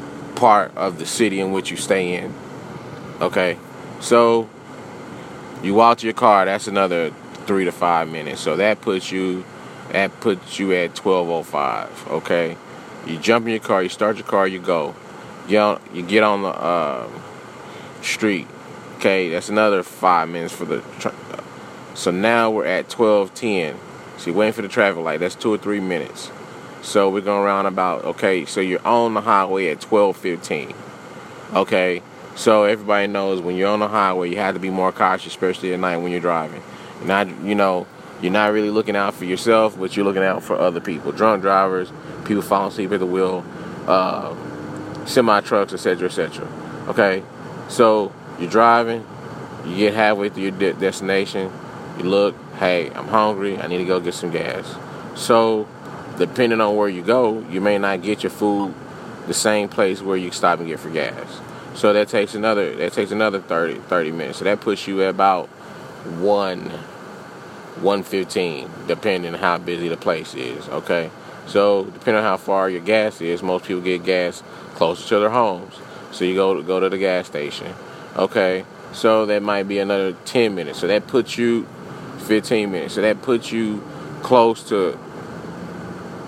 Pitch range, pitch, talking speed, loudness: 90-105 Hz, 100 Hz, 180 wpm, -20 LUFS